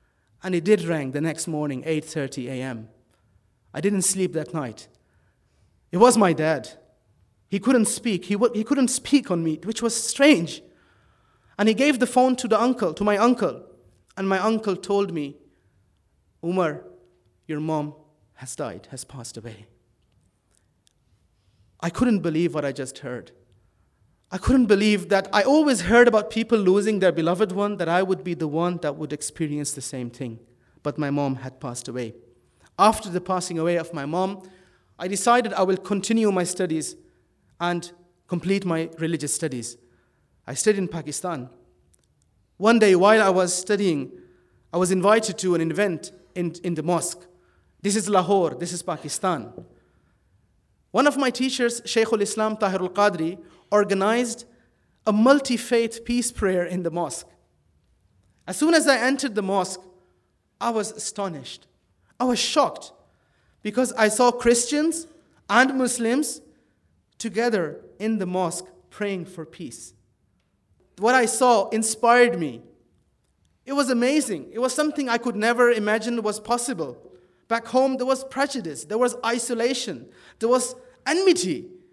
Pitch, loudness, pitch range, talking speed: 185 Hz, -23 LUFS, 140-230 Hz, 155 wpm